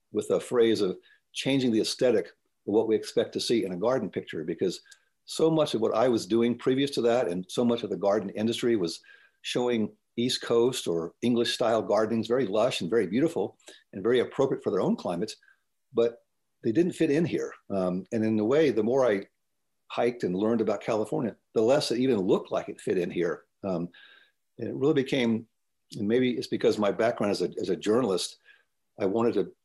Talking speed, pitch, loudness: 210 wpm, 120 Hz, -27 LUFS